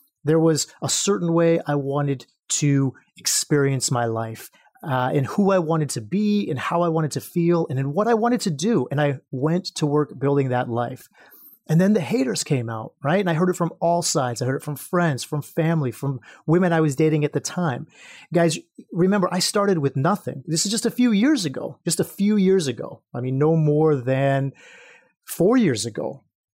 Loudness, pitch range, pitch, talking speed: -22 LUFS, 140-180 Hz, 160 Hz, 215 wpm